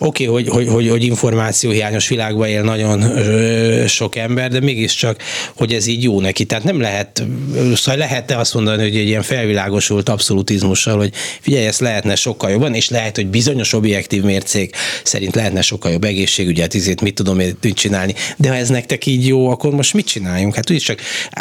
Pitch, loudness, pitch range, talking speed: 110 Hz, -15 LUFS, 100-125 Hz, 185 wpm